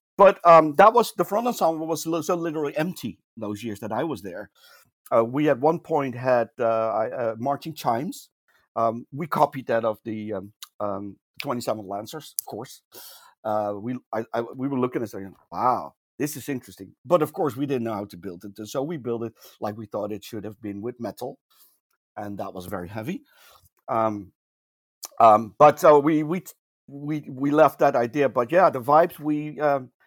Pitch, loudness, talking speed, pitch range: 125 Hz, -23 LUFS, 195 wpm, 110-150 Hz